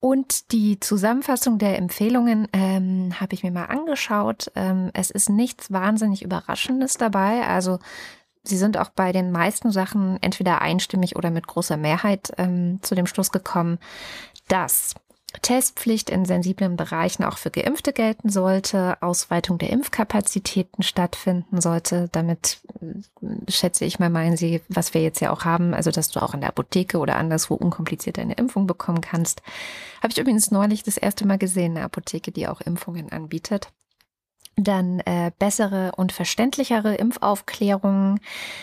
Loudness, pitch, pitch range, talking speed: -22 LUFS, 190 Hz, 175-210 Hz, 150 wpm